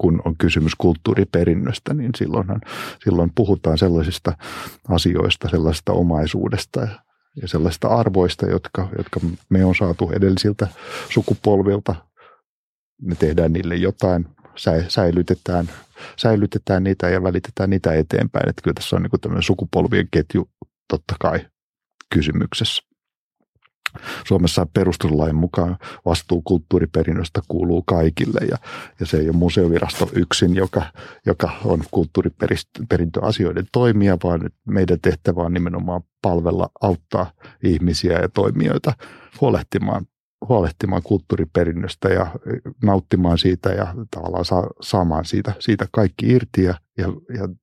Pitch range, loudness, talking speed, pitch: 85-100 Hz, -20 LUFS, 115 wpm, 90 Hz